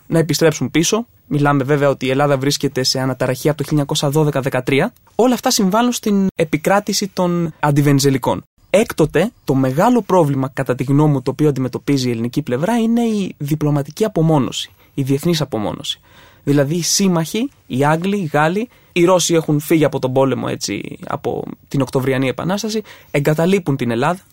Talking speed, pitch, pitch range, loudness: 160 wpm, 150 Hz, 140-180 Hz, -17 LUFS